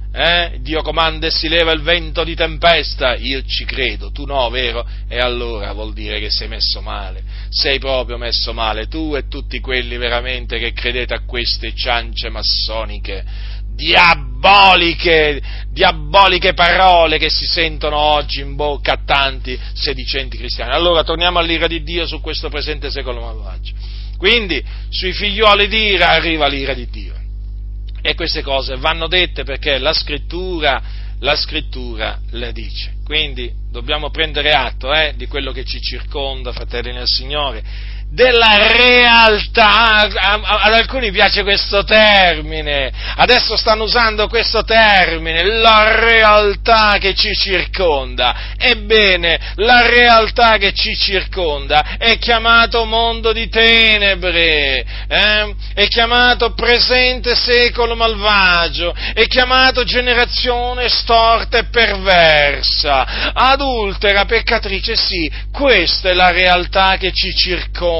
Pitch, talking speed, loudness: 160 Hz, 130 wpm, -13 LUFS